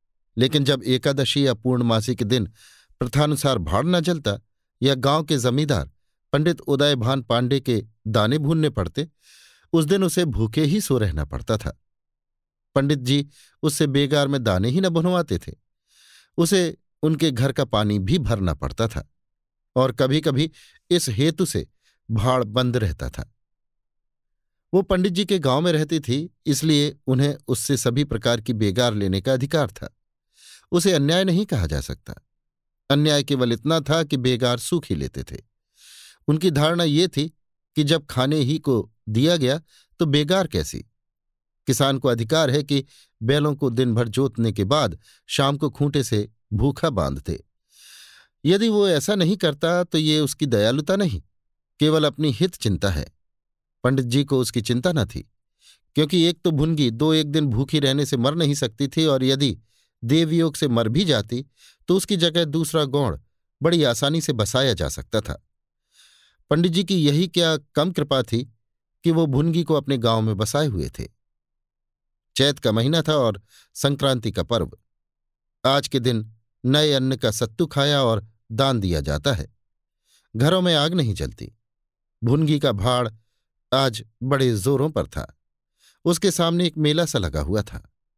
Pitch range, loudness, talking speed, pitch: 115-155 Hz, -21 LUFS, 165 wpm, 135 Hz